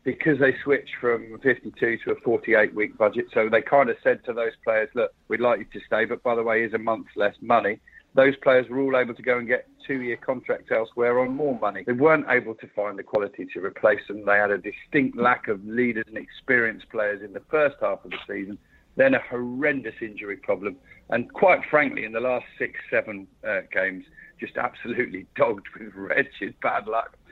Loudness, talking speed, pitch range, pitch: -24 LUFS, 215 wpm, 110-135 Hz, 120 Hz